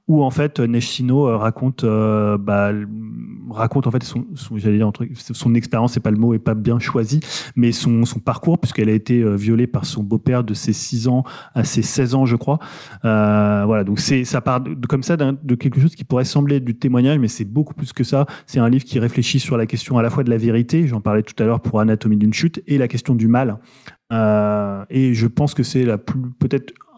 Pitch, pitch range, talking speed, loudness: 120 Hz, 110-135 Hz, 230 wpm, -18 LUFS